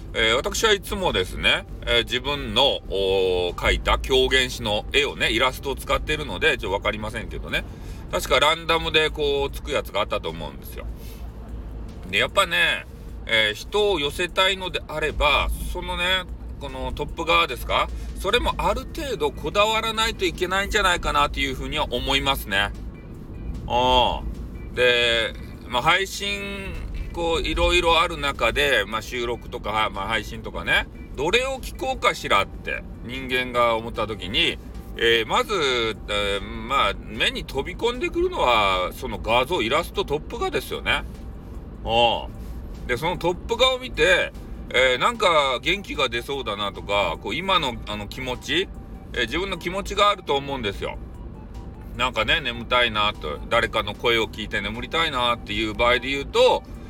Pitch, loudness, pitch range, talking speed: 130 Hz, -22 LUFS, 110-185 Hz, 330 characters per minute